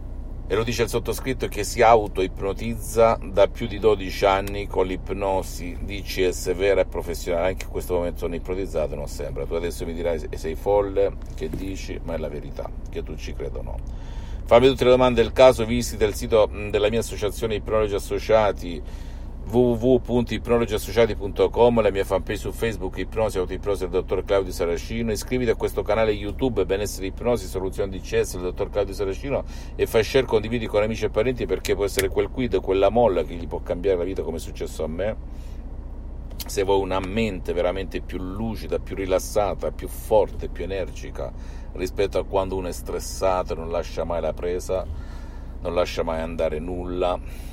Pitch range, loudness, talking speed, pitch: 85-110 Hz, -24 LUFS, 180 wpm, 95 Hz